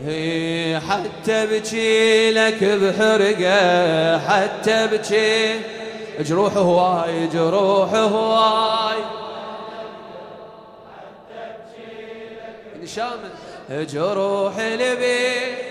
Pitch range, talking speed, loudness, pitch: 195-220 Hz, 60 wpm, -18 LUFS, 220 Hz